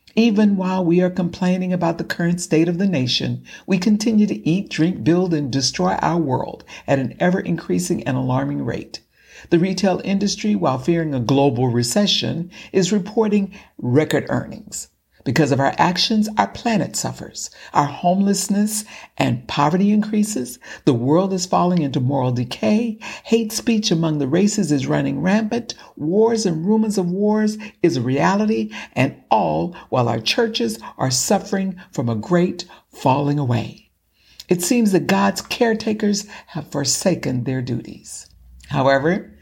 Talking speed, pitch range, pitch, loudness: 150 wpm, 140-205 Hz, 180 Hz, -19 LUFS